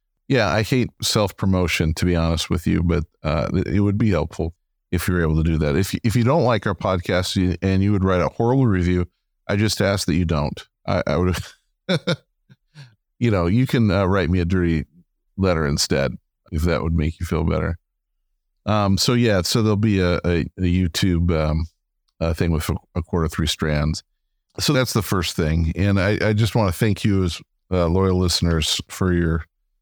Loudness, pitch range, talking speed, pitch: -21 LUFS, 85-105 Hz, 205 wpm, 90 Hz